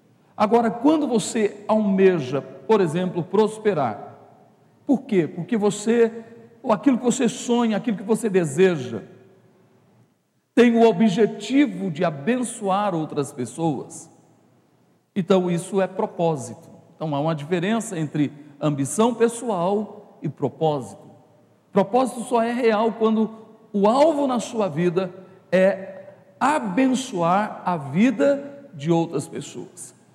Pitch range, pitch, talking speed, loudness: 170-230 Hz, 205 Hz, 115 wpm, -22 LUFS